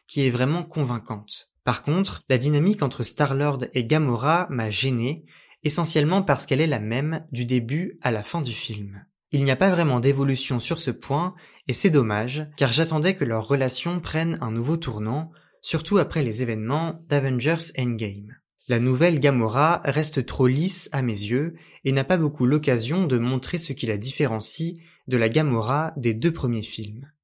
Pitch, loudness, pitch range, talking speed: 140 Hz, -23 LUFS, 125-160 Hz, 180 wpm